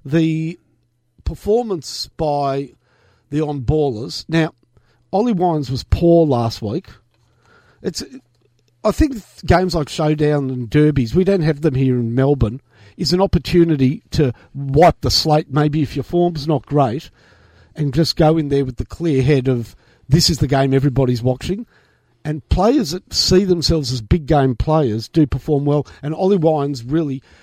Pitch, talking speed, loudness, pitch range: 145 Hz, 155 wpm, -17 LUFS, 125-160 Hz